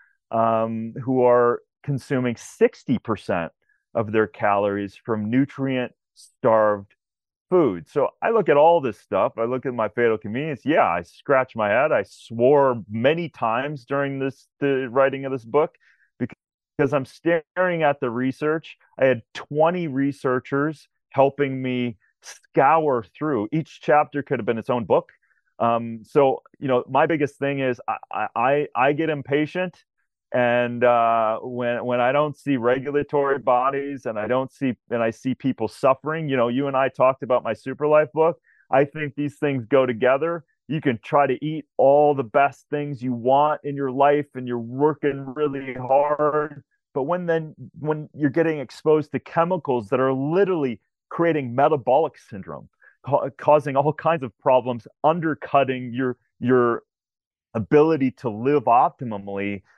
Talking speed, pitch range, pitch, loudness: 160 wpm, 125-150 Hz, 135 Hz, -22 LUFS